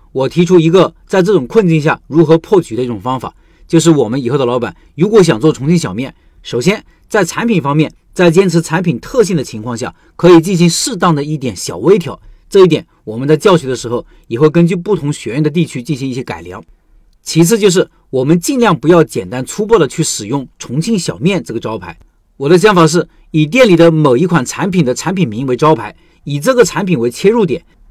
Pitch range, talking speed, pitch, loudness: 130-180 Hz, 325 characters per minute, 165 Hz, -12 LUFS